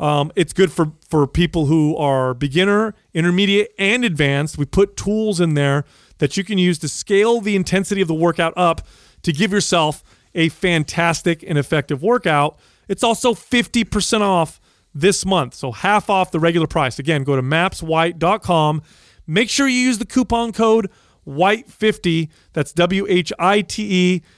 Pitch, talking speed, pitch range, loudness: 175 Hz, 155 wpm, 155-205 Hz, -18 LUFS